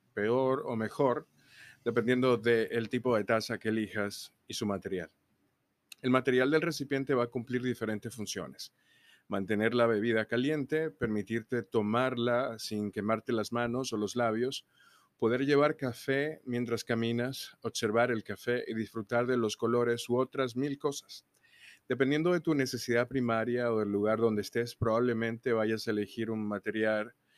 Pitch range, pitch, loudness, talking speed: 110-125 Hz, 120 Hz, -31 LUFS, 150 wpm